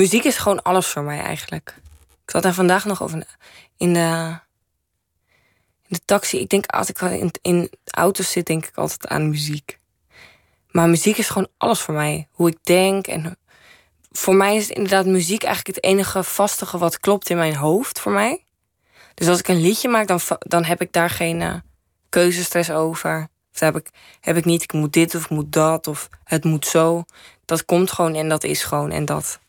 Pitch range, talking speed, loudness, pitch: 155-185 Hz, 200 wpm, -19 LUFS, 170 Hz